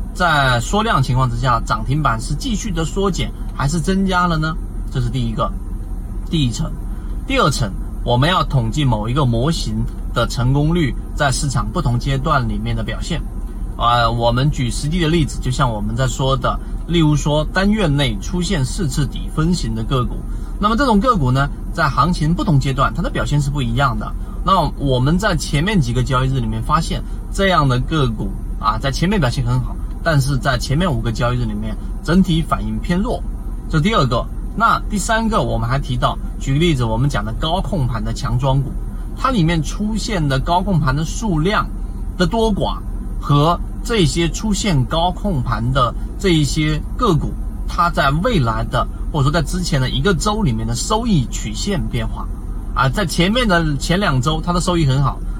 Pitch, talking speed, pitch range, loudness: 140 Hz, 275 characters per minute, 115-170 Hz, -18 LUFS